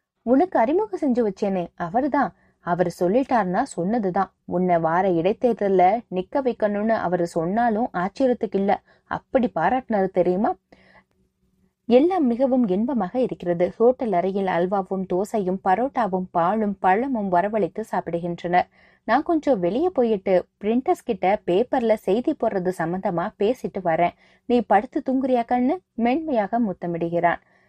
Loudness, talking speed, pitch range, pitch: -22 LUFS, 110 wpm, 180-245 Hz, 215 Hz